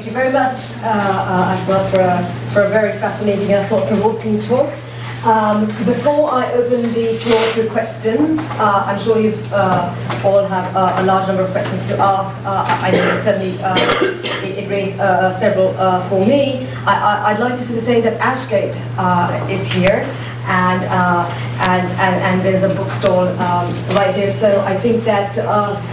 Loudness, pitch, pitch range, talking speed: -16 LUFS, 200 Hz, 185-225 Hz, 195 wpm